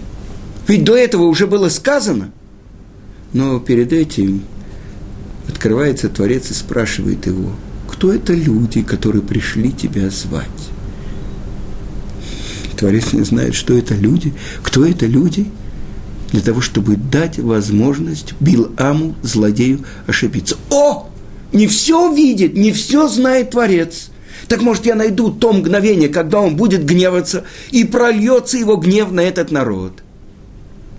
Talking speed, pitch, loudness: 120 wpm, 130 Hz, -14 LUFS